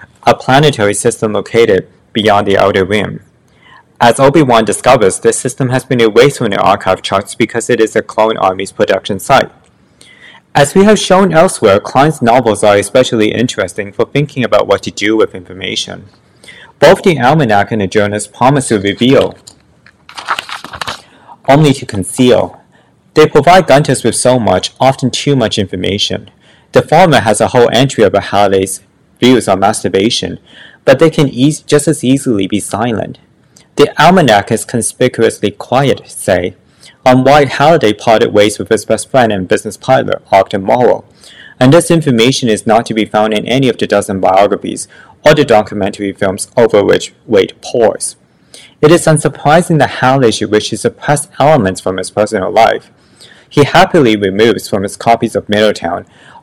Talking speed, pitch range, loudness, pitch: 160 wpm, 105-135 Hz, -10 LUFS, 115 Hz